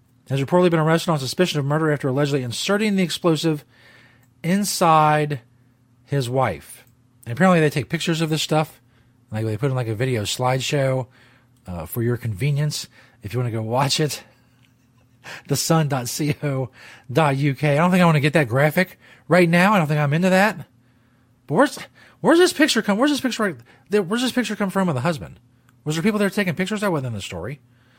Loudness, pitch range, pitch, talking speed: -20 LUFS, 125-170 Hz, 145 Hz, 195 wpm